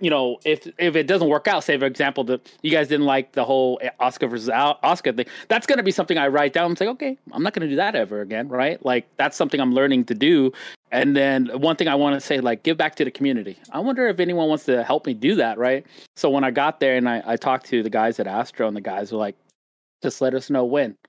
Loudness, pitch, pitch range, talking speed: -21 LUFS, 140 Hz, 125-165 Hz, 280 wpm